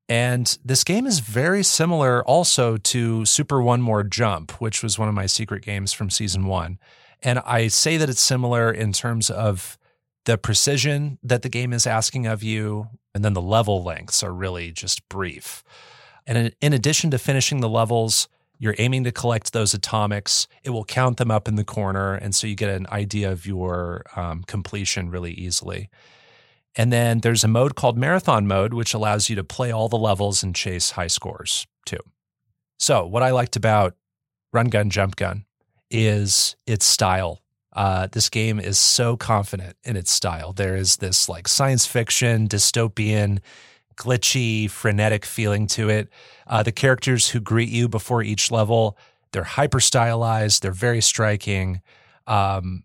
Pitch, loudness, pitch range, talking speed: 110 Hz, -20 LUFS, 100-120 Hz, 175 wpm